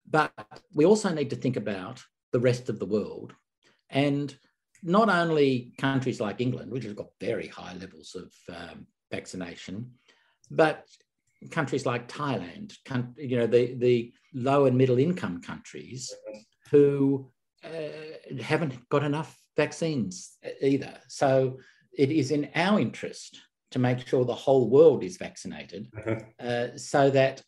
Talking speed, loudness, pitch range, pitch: 140 wpm, -26 LUFS, 125-150 Hz, 135 Hz